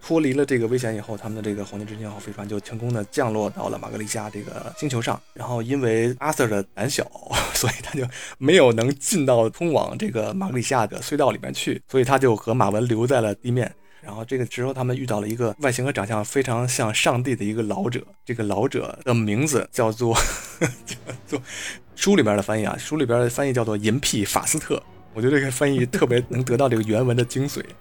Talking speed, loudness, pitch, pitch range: 350 characters per minute, -23 LUFS, 120 Hz, 105-130 Hz